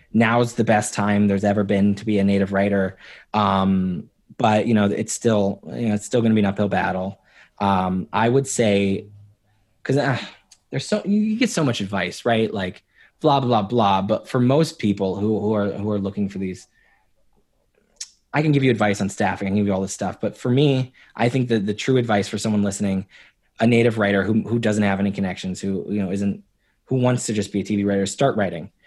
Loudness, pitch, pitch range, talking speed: -21 LUFS, 105 Hz, 100-115 Hz, 220 wpm